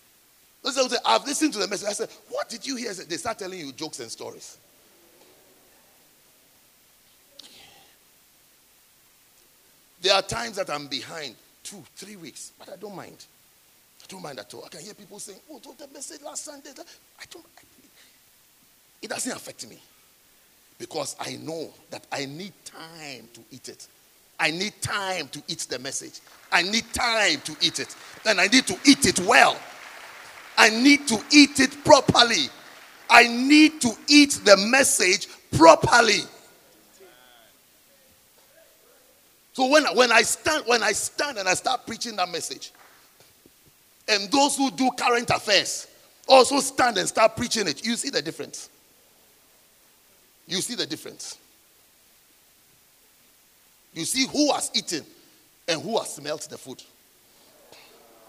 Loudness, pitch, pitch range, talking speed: -21 LUFS, 240 Hz, 195-285 Hz, 145 wpm